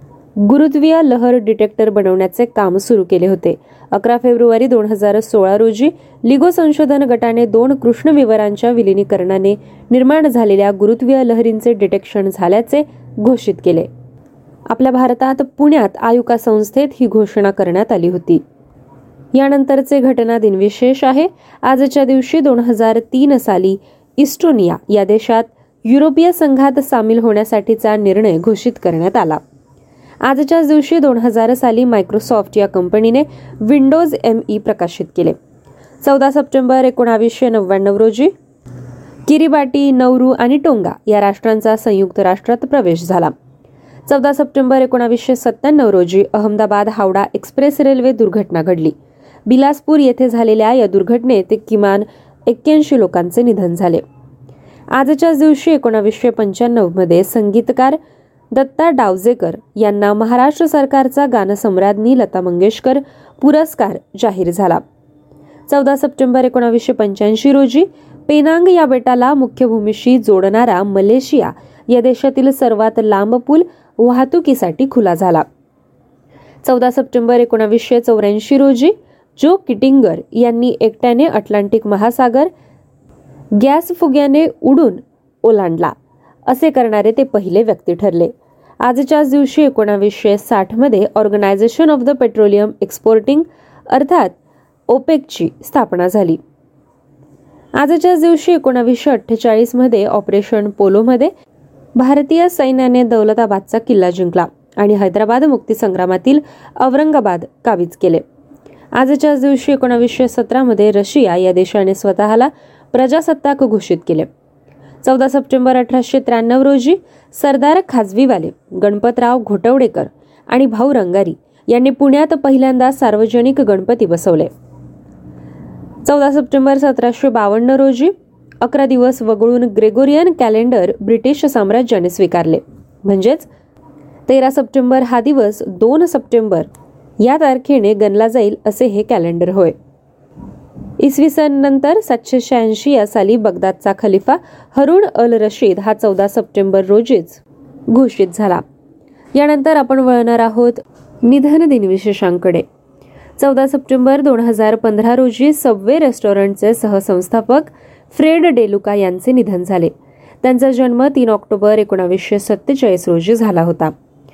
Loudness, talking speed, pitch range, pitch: -12 LUFS, 110 wpm, 200-270 Hz, 235 Hz